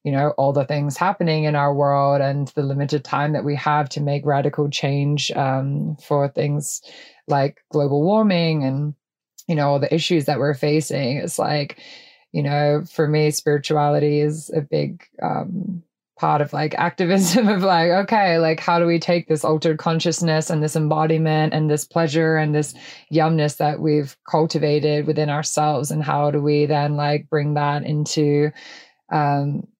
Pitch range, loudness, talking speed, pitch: 145-160 Hz, -20 LUFS, 170 wpm, 150 Hz